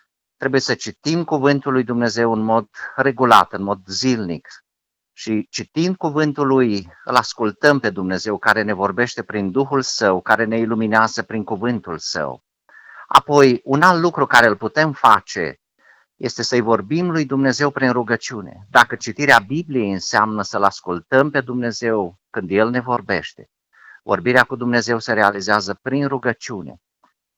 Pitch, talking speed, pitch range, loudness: 120 Hz, 145 wpm, 105-135 Hz, -18 LUFS